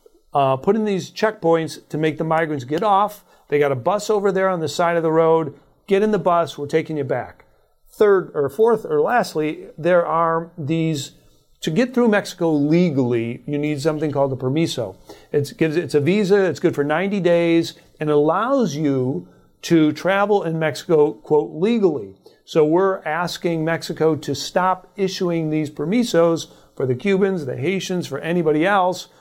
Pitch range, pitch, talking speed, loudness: 150-190 Hz, 165 Hz, 175 wpm, -20 LUFS